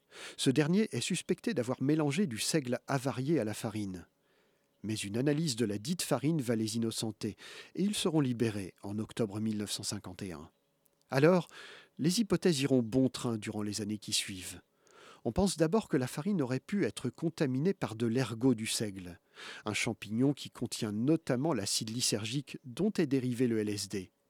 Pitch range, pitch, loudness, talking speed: 110-155 Hz, 125 Hz, -33 LUFS, 165 wpm